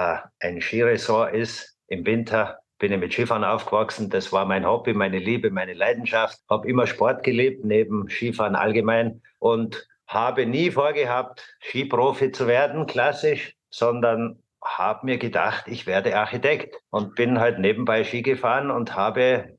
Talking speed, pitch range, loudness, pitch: 150 wpm, 110-125 Hz, -23 LUFS, 115 Hz